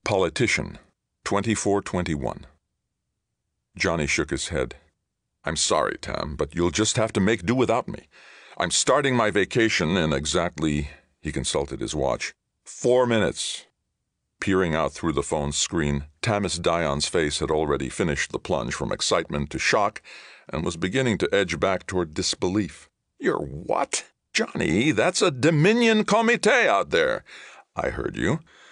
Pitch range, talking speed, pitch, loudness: 80-115 Hz, 140 wpm, 95 Hz, -24 LUFS